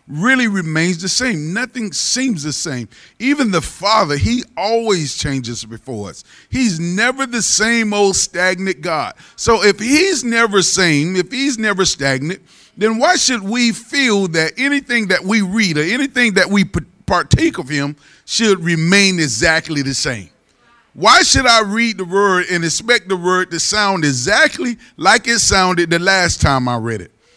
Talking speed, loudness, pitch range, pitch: 165 wpm, -14 LUFS, 165-230 Hz, 195 Hz